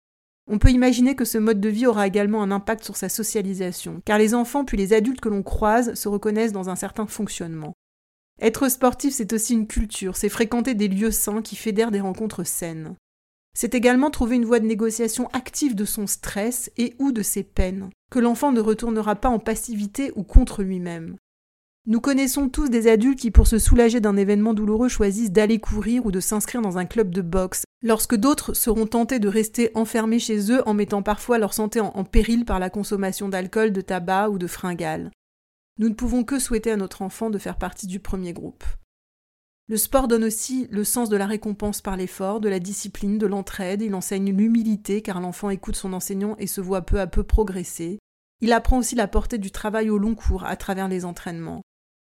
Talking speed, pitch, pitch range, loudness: 210 wpm, 215 Hz, 195-230 Hz, -22 LUFS